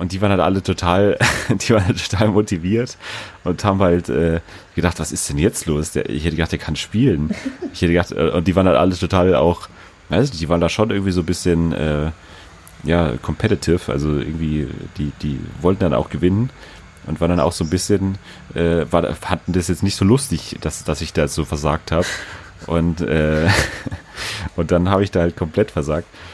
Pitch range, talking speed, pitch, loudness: 80-95 Hz, 200 wpm, 90 Hz, -19 LUFS